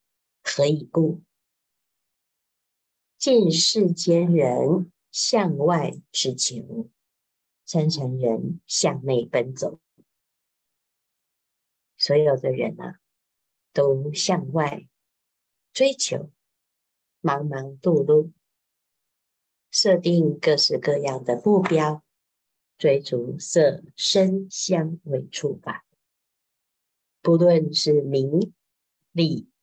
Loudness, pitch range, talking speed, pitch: -22 LUFS, 130-175 Hz, 110 characters per minute, 150 Hz